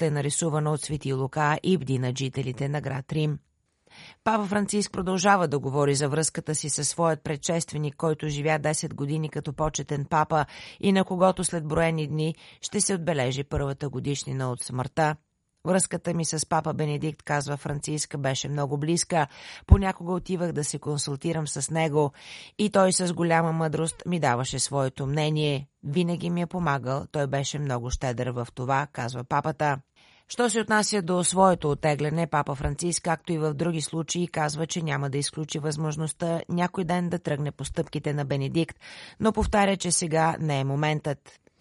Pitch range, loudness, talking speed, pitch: 145-170 Hz, -26 LUFS, 165 wpm, 155 Hz